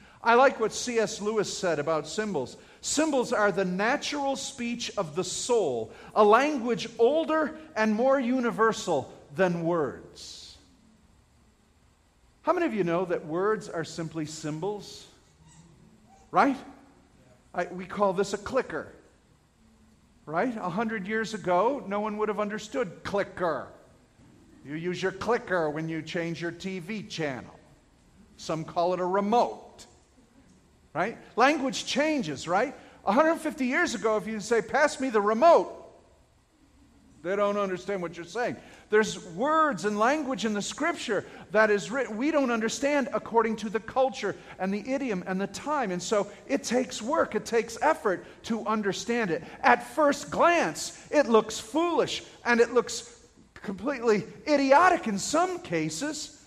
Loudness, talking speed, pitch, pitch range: -27 LUFS, 145 wpm, 220 Hz, 195-265 Hz